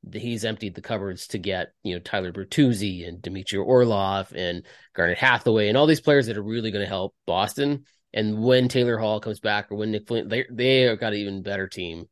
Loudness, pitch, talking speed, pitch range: -24 LUFS, 110 Hz, 225 wpm, 95-120 Hz